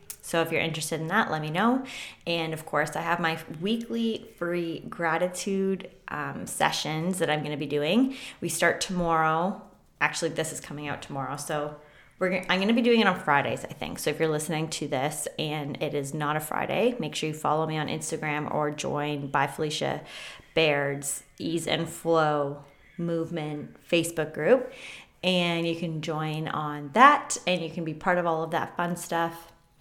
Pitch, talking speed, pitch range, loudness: 160 Hz, 190 wpm, 150-180 Hz, -27 LUFS